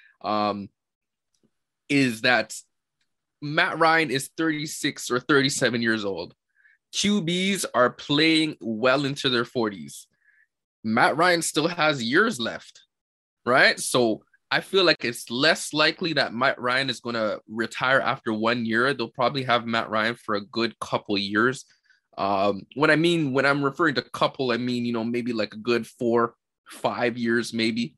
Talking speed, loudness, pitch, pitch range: 155 wpm, -23 LUFS, 125 Hz, 115-150 Hz